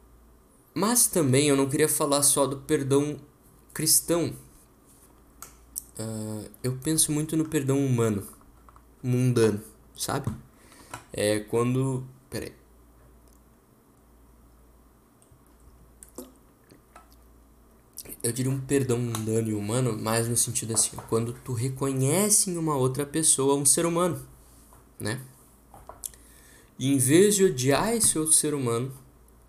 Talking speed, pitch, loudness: 110 wpm, 125 Hz, -24 LUFS